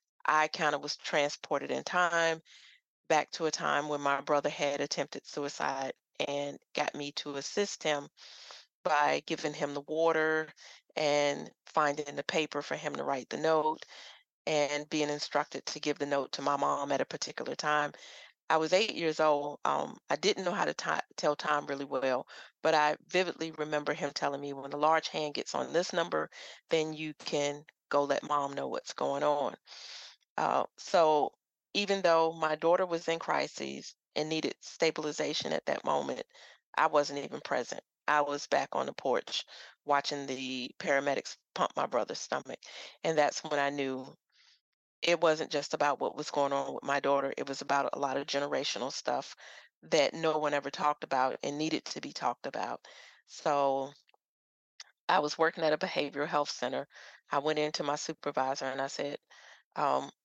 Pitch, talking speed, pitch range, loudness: 150 Hz, 180 wpm, 140-155 Hz, -32 LUFS